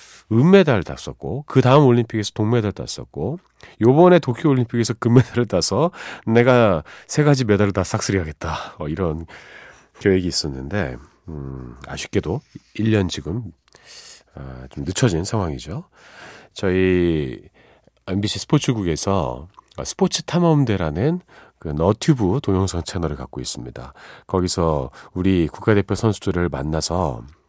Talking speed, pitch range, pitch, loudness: 280 characters per minute, 80-120 Hz, 95 Hz, -20 LUFS